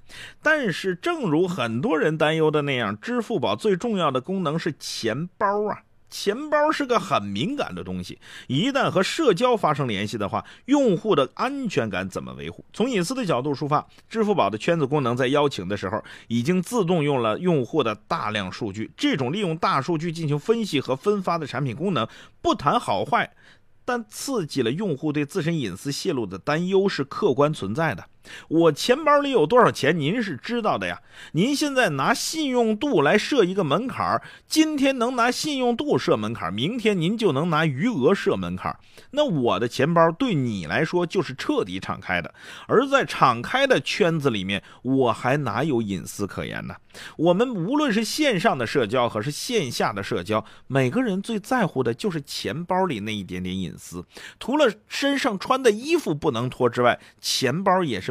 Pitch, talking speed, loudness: 165 Hz, 280 characters per minute, -23 LUFS